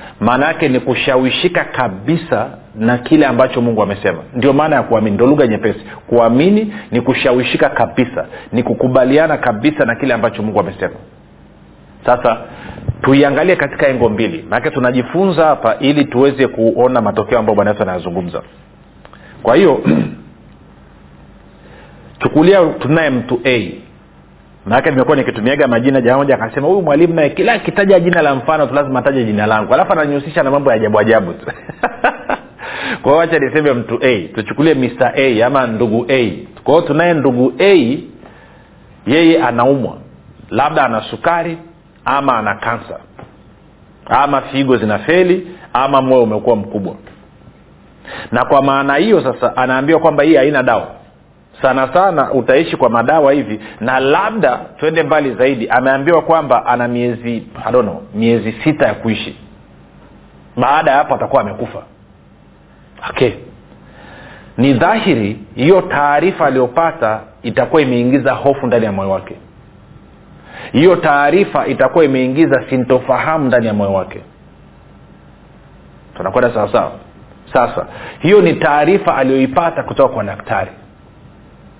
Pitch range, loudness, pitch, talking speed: 110-150 Hz, -13 LUFS, 130 Hz, 130 wpm